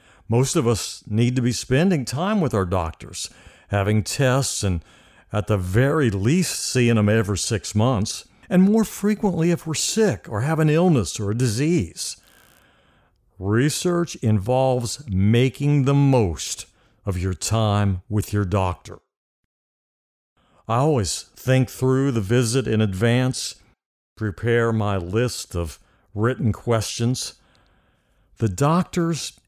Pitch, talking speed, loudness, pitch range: 115 Hz, 130 wpm, -21 LUFS, 100-135 Hz